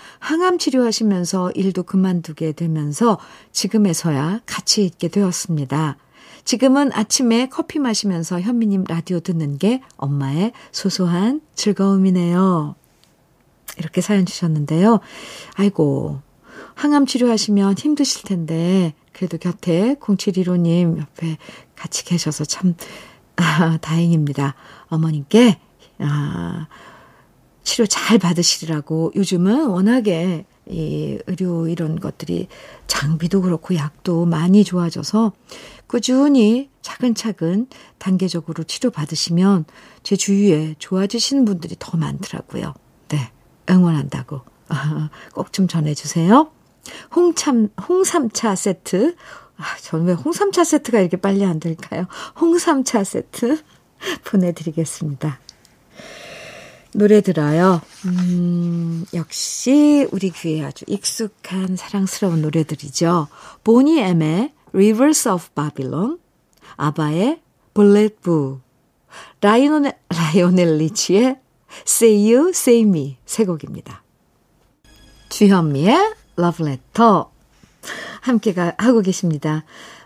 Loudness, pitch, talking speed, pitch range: -18 LUFS, 185 Hz, 260 characters per minute, 165-225 Hz